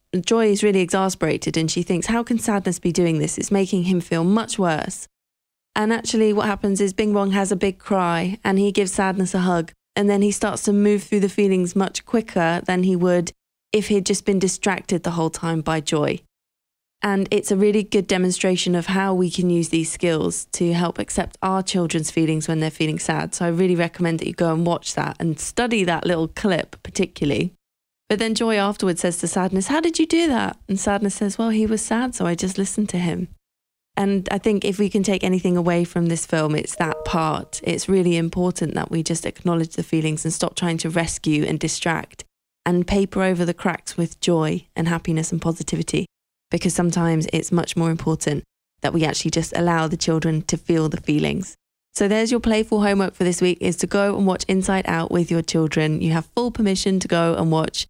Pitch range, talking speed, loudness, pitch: 165-200 Hz, 215 wpm, -21 LUFS, 180 Hz